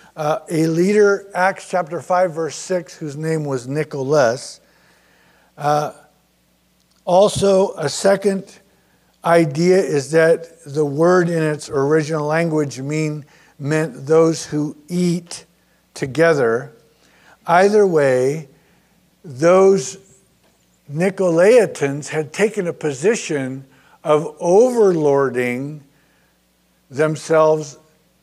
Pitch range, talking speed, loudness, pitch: 145-180 Hz, 90 wpm, -17 LUFS, 155 Hz